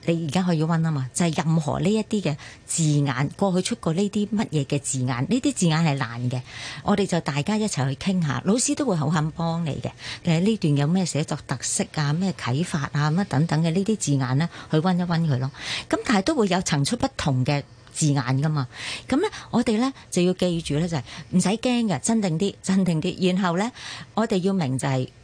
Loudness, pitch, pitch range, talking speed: -24 LUFS, 165 Hz, 145-195 Hz, 315 characters per minute